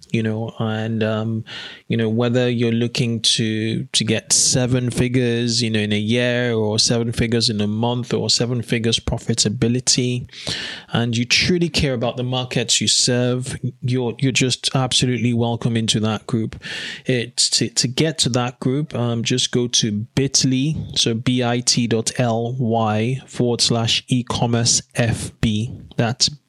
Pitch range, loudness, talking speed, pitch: 115-125 Hz, -19 LUFS, 150 wpm, 120 Hz